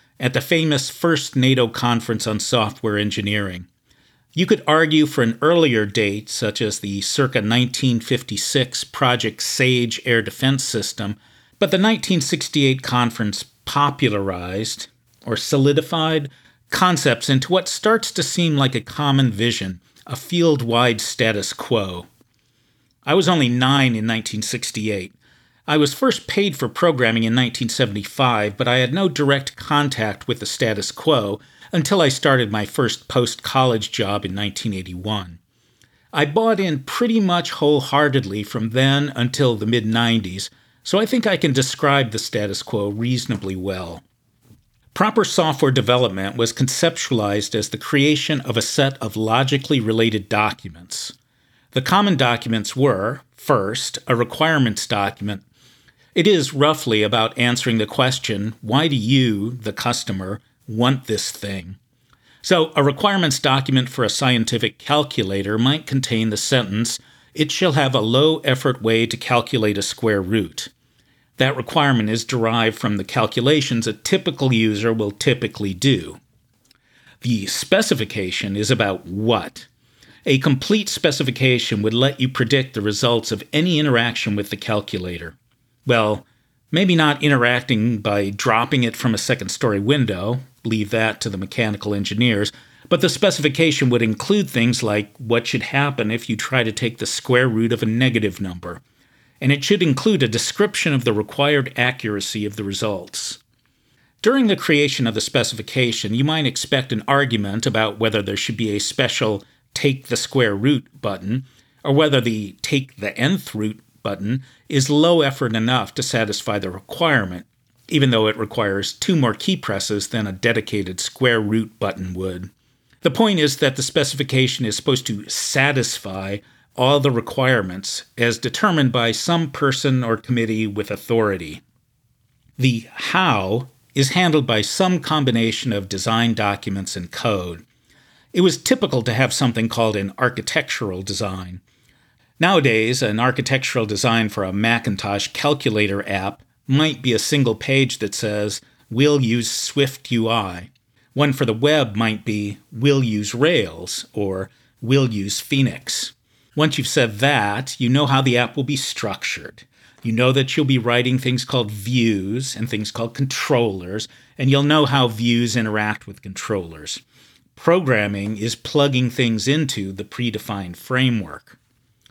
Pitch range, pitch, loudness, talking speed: 110-140 Hz, 120 Hz, -19 LUFS, 150 wpm